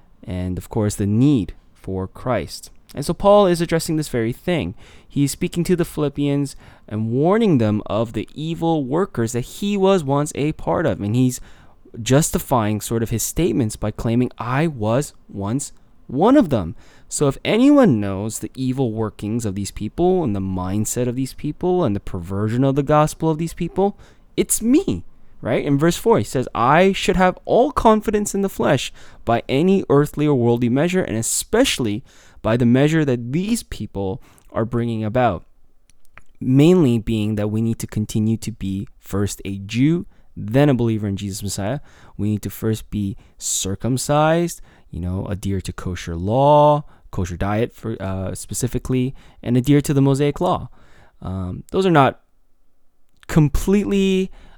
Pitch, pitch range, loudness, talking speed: 125 Hz, 105-155 Hz, -20 LUFS, 170 wpm